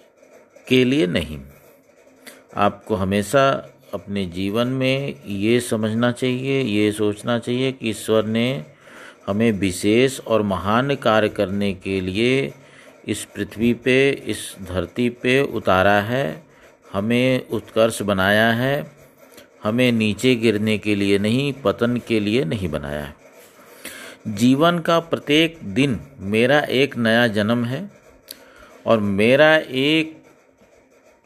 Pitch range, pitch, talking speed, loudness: 100-130 Hz, 115 Hz, 115 wpm, -20 LUFS